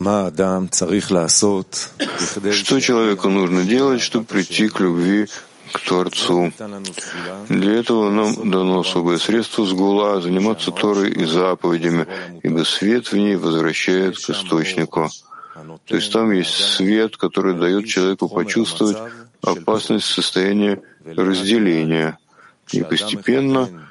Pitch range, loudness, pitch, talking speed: 90-105 Hz, -18 LUFS, 95 Hz, 110 wpm